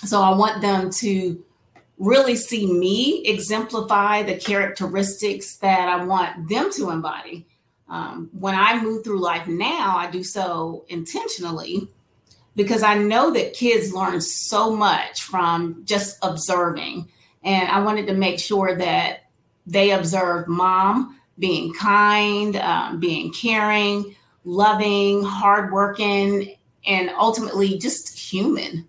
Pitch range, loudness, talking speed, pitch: 180-210 Hz, -20 LUFS, 125 wpm, 195 Hz